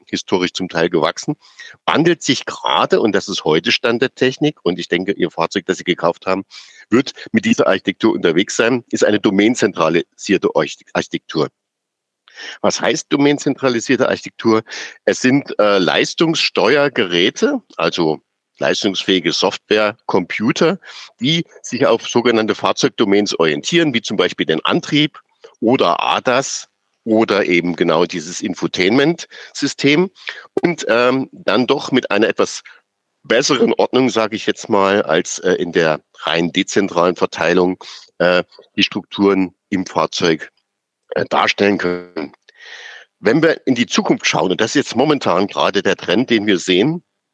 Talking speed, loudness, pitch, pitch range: 135 wpm, -16 LUFS, 110 Hz, 95-140 Hz